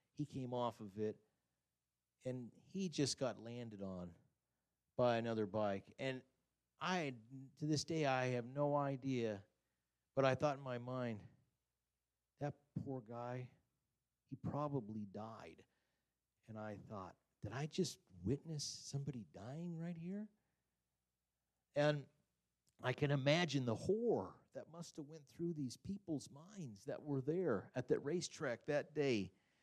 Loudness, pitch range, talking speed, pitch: -43 LUFS, 105-145 Hz, 140 wpm, 130 Hz